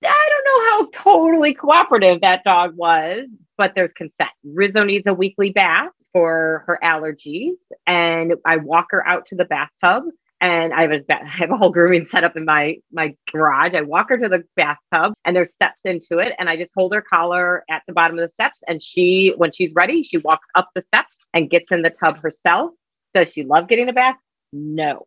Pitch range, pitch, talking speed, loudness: 165-200 Hz, 175 Hz, 215 wpm, -17 LUFS